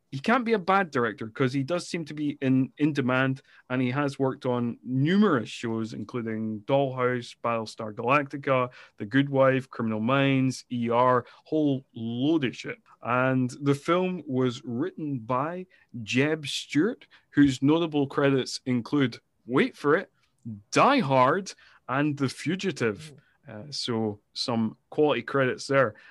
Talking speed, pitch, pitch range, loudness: 140 wpm, 135 Hz, 120-145 Hz, -26 LUFS